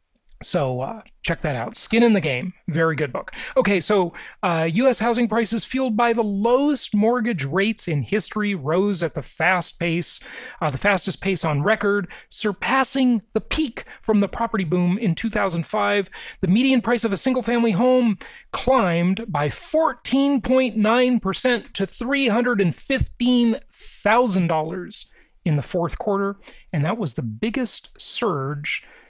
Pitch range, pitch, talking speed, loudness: 175-240 Hz, 210 Hz, 140 wpm, -21 LUFS